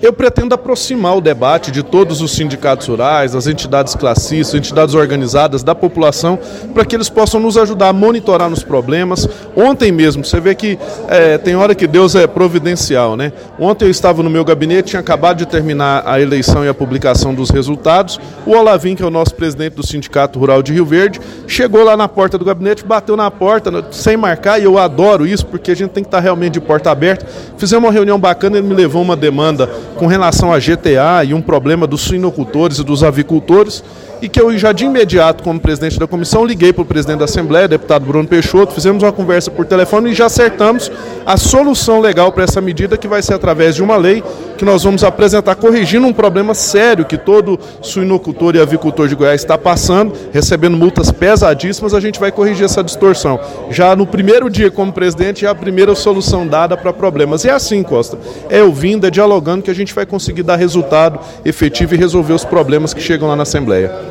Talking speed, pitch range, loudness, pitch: 205 wpm, 155-205 Hz, -11 LUFS, 180 Hz